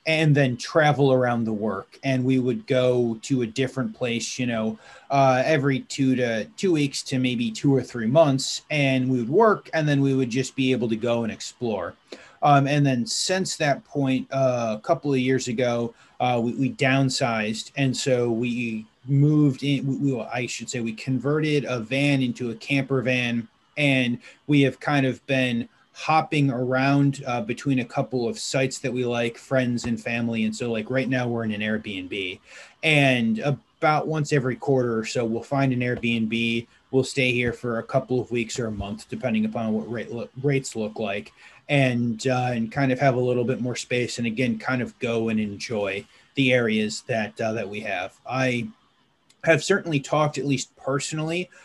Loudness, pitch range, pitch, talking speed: -24 LUFS, 115-135 Hz, 130 Hz, 195 wpm